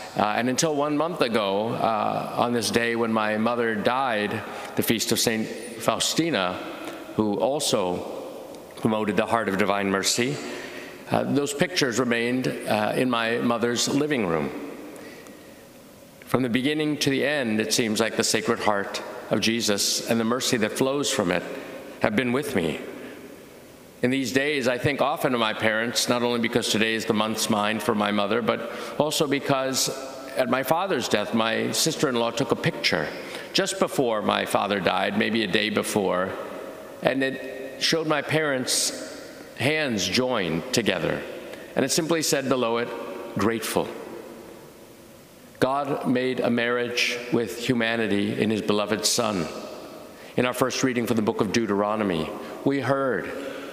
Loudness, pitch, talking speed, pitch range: -24 LUFS, 120 Hz, 155 wpm, 110-130 Hz